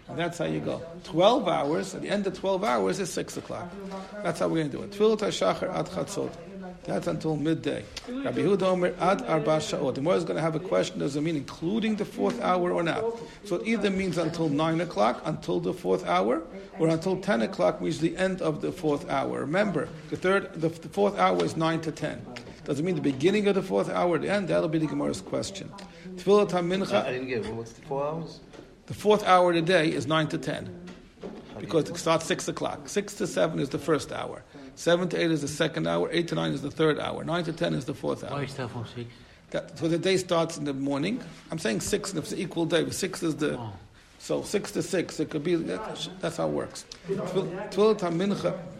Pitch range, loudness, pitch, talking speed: 155-190 Hz, -28 LUFS, 170 Hz, 215 wpm